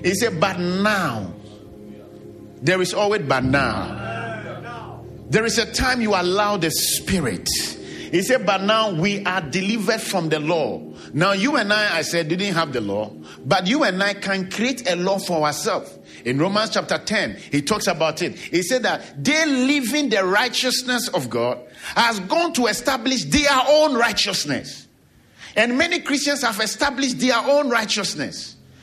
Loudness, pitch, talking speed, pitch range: -20 LUFS, 205 Hz, 165 wpm, 175-250 Hz